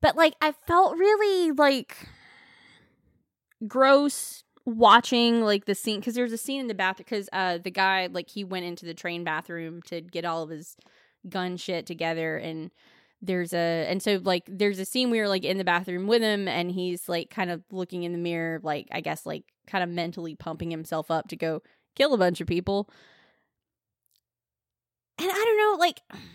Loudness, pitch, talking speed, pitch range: -26 LUFS, 185 Hz, 195 wpm, 170-230 Hz